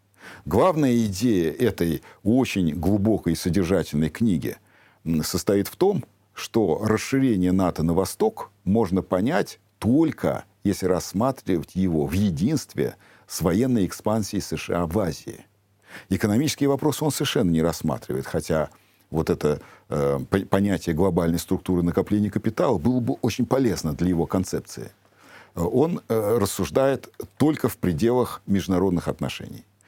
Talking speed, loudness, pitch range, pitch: 120 wpm, -24 LUFS, 85-110 Hz, 95 Hz